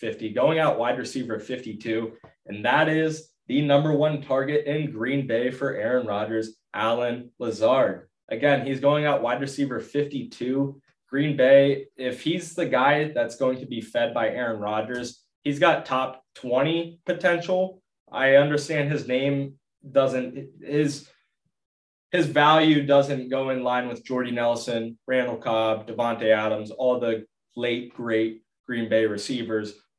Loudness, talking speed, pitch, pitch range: -24 LUFS, 145 wpm, 130 Hz, 115-145 Hz